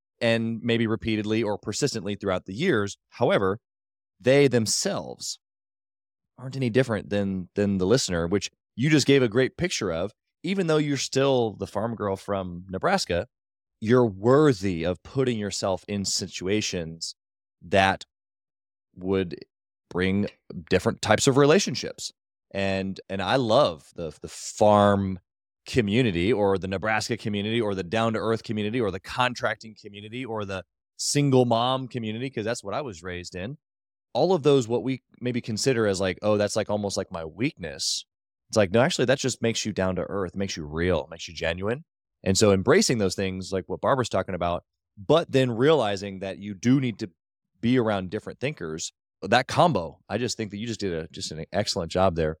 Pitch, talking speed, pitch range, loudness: 105 Hz, 175 wpm, 95-120 Hz, -25 LUFS